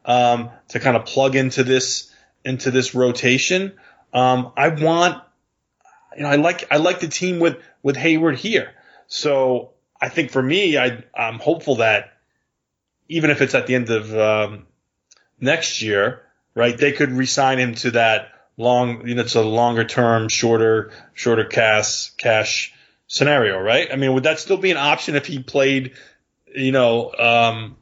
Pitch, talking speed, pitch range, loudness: 130 Hz, 170 wpm, 115-145 Hz, -18 LUFS